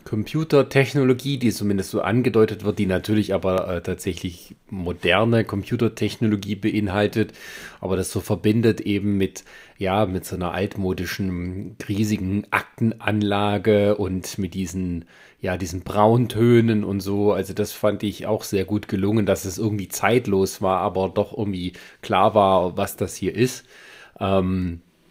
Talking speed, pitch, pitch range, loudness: 140 wpm, 105 Hz, 95-110 Hz, -22 LUFS